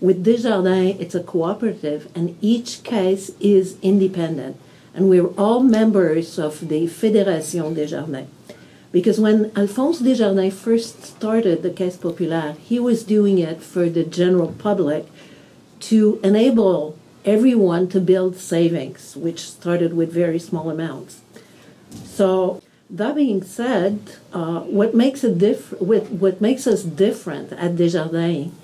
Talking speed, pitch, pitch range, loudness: 130 wpm, 185 Hz, 170-210 Hz, -19 LUFS